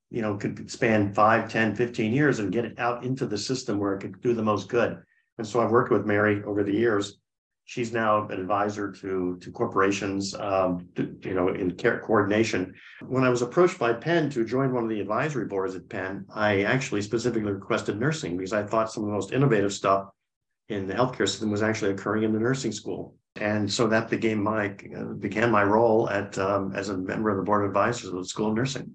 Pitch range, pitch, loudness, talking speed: 100-115 Hz, 105 Hz, -26 LUFS, 225 wpm